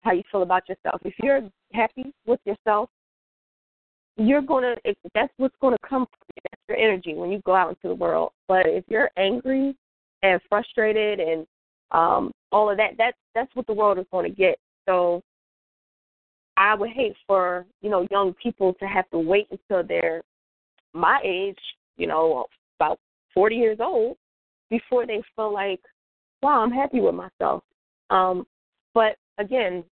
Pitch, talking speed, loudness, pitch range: 210 Hz, 170 wpm, -23 LUFS, 185-245 Hz